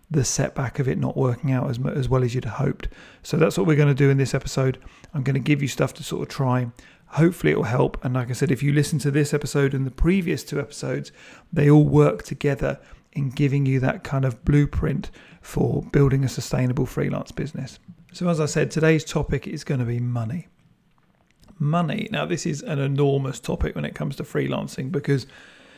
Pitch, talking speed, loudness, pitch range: 140 Hz, 215 wpm, -23 LUFS, 130-155 Hz